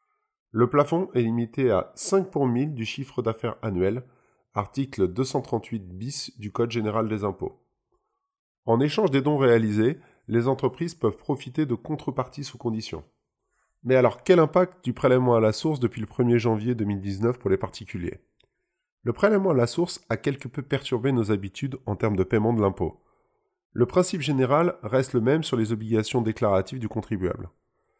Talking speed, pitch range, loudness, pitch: 170 wpm, 110-140 Hz, -25 LUFS, 125 Hz